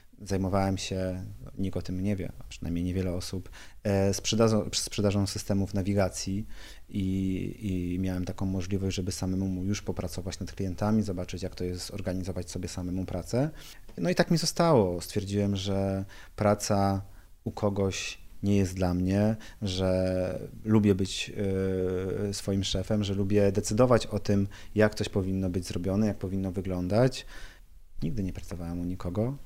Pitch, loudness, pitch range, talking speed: 95 Hz, -29 LUFS, 95-105 Hz, 140 wpm